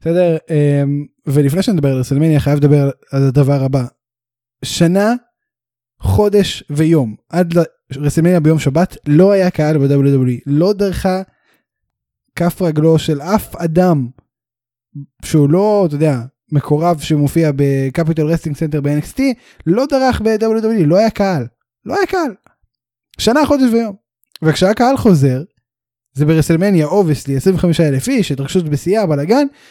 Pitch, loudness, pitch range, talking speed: 160 Hz, -14 LUFS, 140-190 Hz, 125 wpm